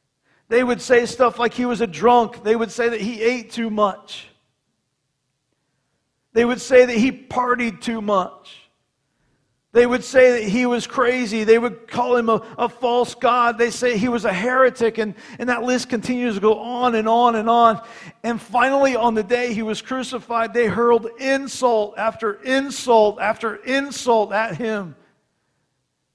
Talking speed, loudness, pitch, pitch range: 170 wpm, -19 LUFS, 230 Hz, 210-245 Hz